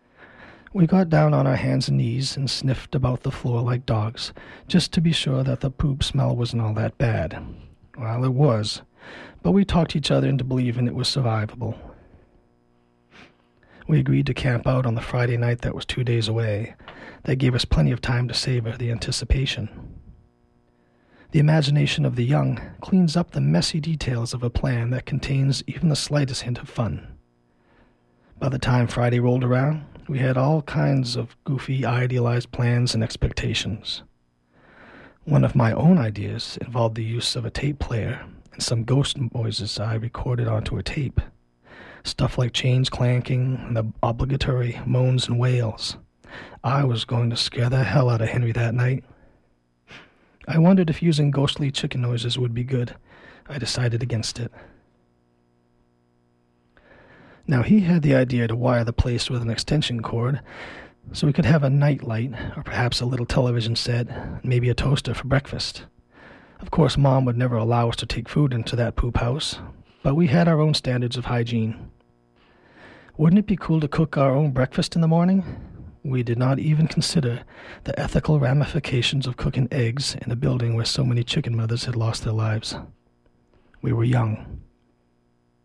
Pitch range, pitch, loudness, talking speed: 115-135 Hz, 125 Hz, -23 LUFS, 175 wpm